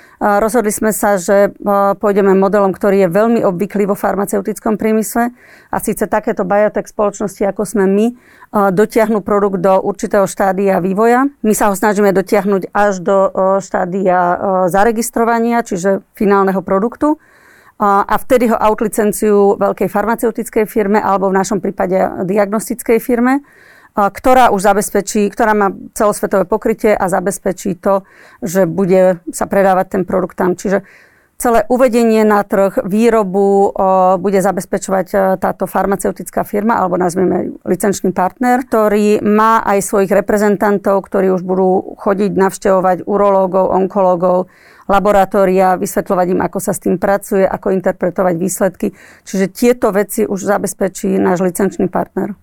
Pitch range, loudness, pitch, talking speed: 190-215 Hz, -14 LUFS, 200 Hz, 135 wpm